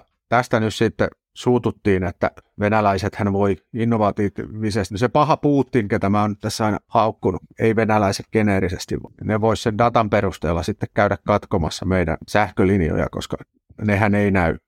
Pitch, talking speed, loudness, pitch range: 105 Hz, 145 wpm, -20 LUFS, 95-115 Hz